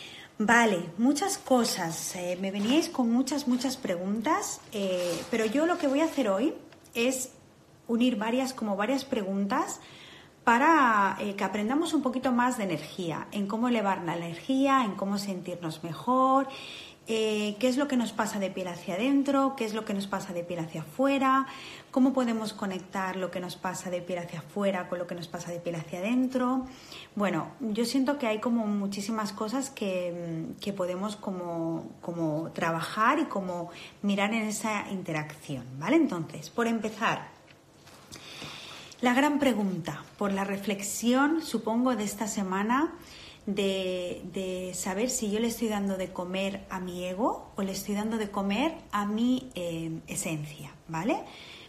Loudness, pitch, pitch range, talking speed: -29 LUFS, 205 Hz, 180-255 Hz, 165 wpm